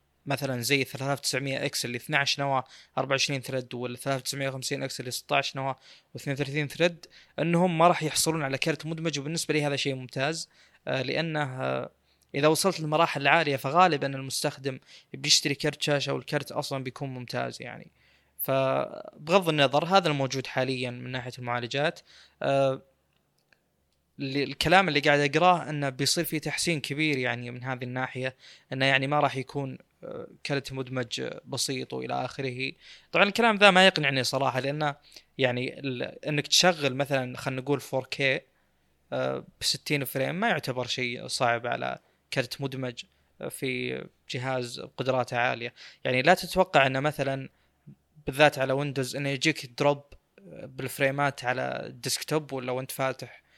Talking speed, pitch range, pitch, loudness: 140 wpm, 130-150 Hz, 135 Hz, -27 LUFS